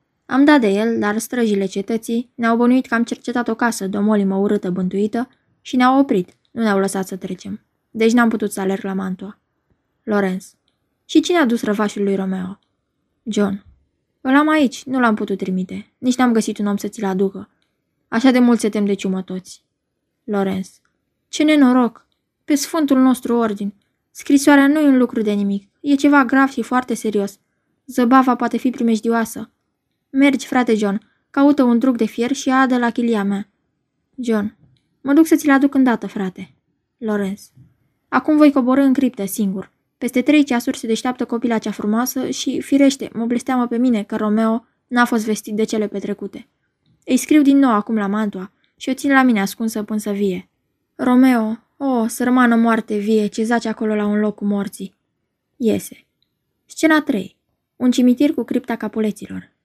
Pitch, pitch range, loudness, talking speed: 230 Hz, 205-255 Hz, -18 LUFS, 175 wpm